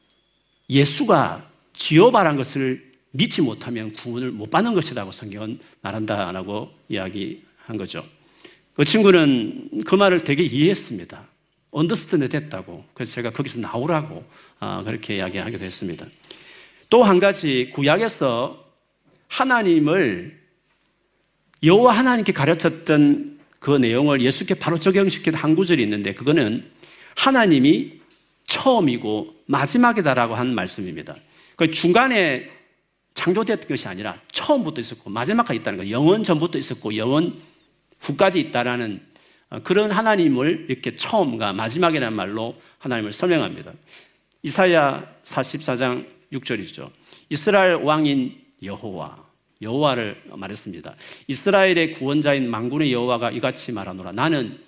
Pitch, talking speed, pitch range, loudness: 150 Hz, 305 characters per minute, 120-190 Hz, -20 LUFS